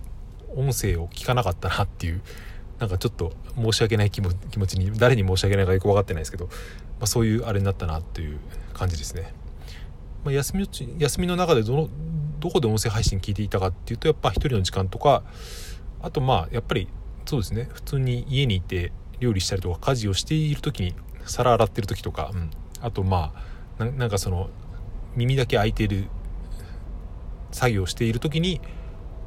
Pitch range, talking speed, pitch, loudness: 90-120 Hz, 390 characters per minute, 100 Hz, -25 LUFS